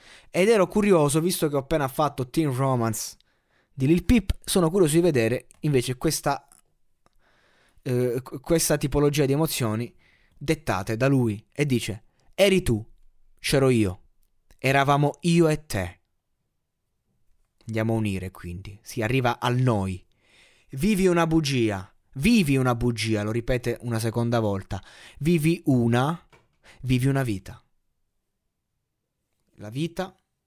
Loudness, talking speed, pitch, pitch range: -24 LUFS, 125 wpm, 130 Hz, 115-160 Hz